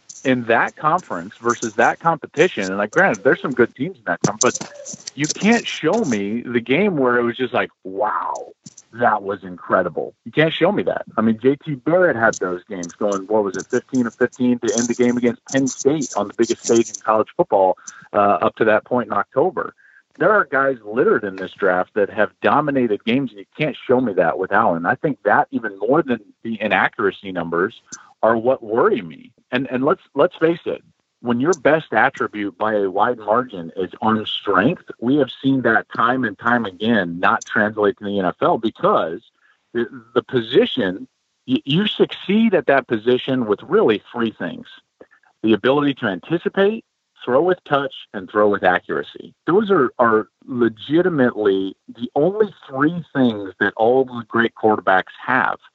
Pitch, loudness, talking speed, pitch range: 120 Hz, -19 LUFS, 185 wpm, 105-140 Hz